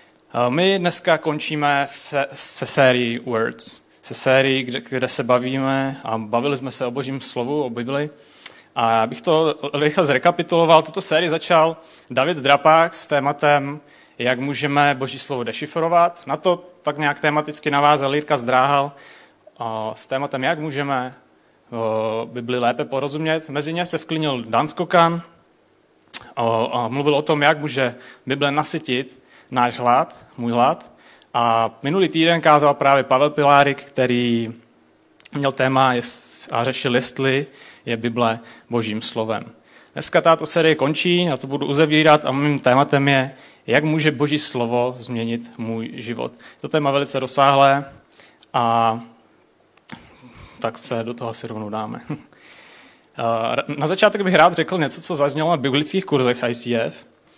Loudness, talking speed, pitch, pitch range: -19 LUFS, 140 wpm, 140 Hz, 120-155 Hz